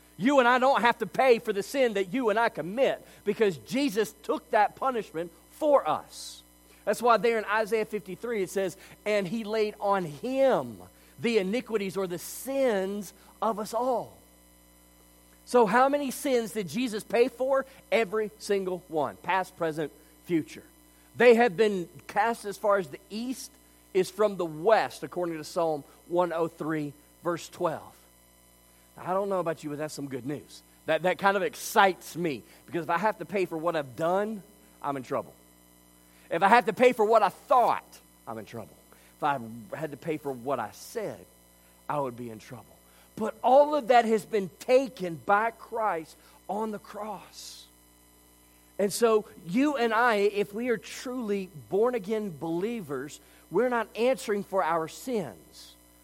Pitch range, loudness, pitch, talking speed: 140-220 Hz, -28 LUFS, 190 Hz, 170 wpm